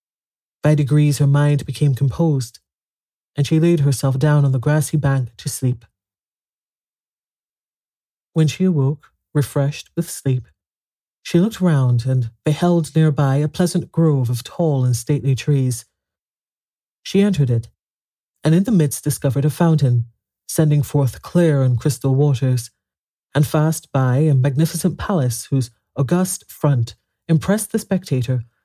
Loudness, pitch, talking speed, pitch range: -18 LUFS, 145 Hz, 135 wpm, 130-160 Hz